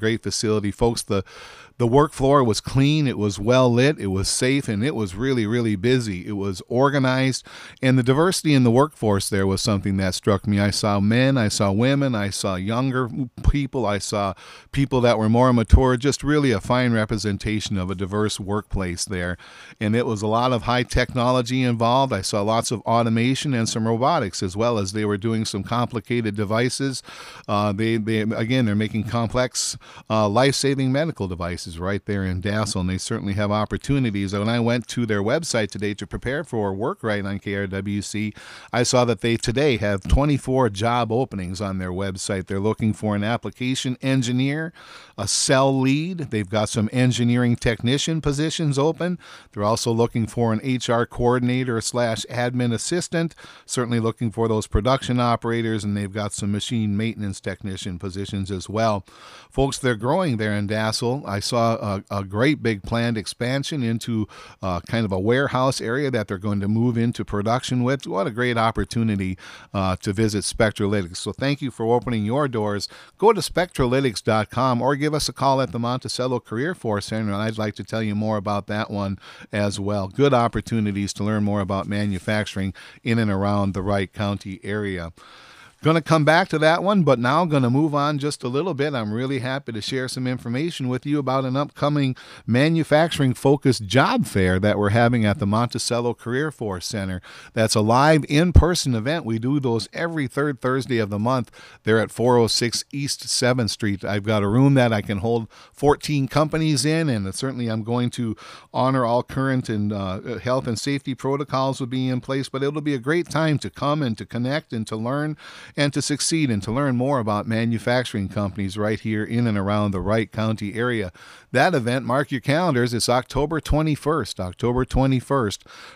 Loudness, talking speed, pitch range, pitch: -22 LUFS, 185 wpm, 105-130 Hz, 115 Hz